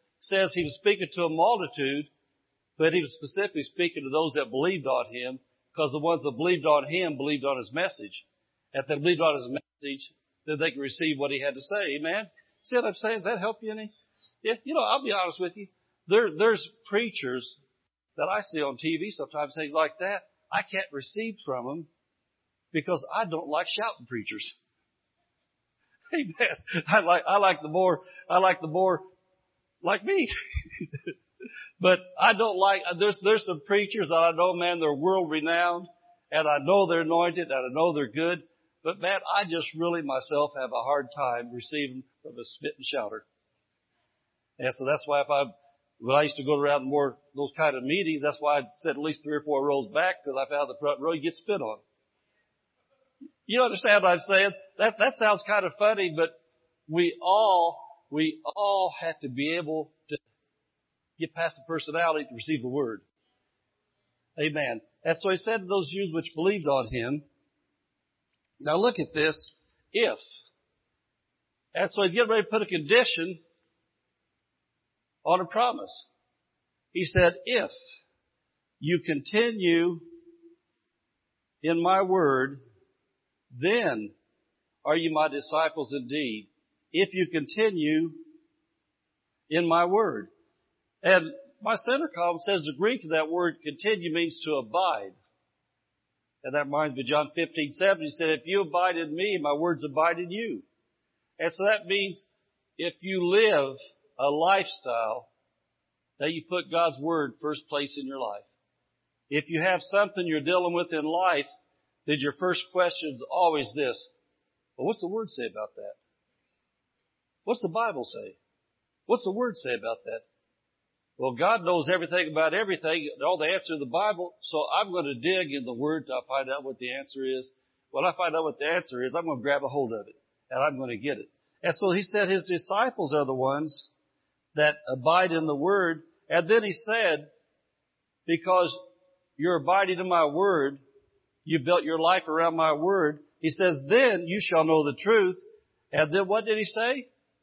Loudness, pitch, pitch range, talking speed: -27 LUFS, 170 Hz, 150-195 Hz, 175 wpm